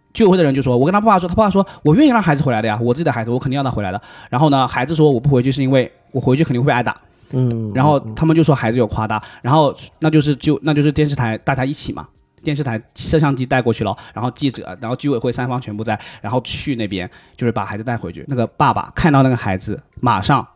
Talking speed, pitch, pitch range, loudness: 410 characters per minute, 130 Hz, 115-150 Hz, -17 LUFS